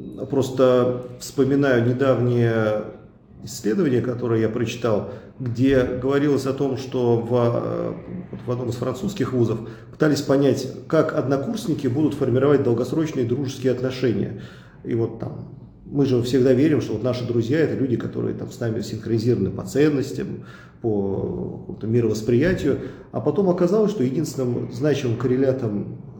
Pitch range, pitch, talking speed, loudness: 115-135 Hz, 125 Hz, 130 wpm, -22 LUFS